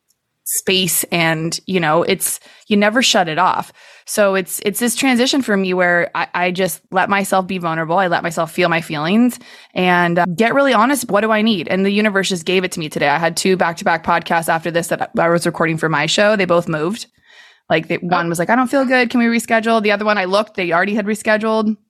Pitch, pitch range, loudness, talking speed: 190 Hz, 170-215 Hz, -16 LUFS, 240 wpm